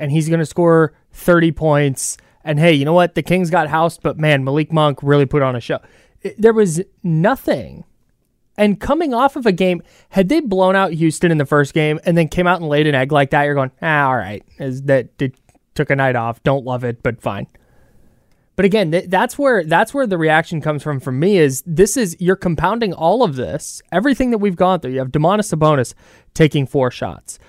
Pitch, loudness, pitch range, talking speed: 160 Hz, -16 LUFS, 145-185 Hz, 225 wpm